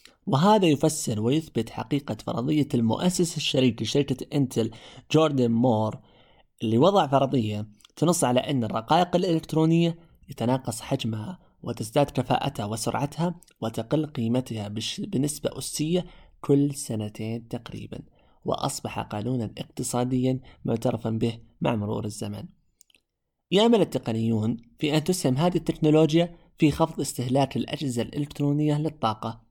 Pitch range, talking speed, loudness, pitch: 115-155 Hz, 105 wpm, -25 LUFS, 130 Hz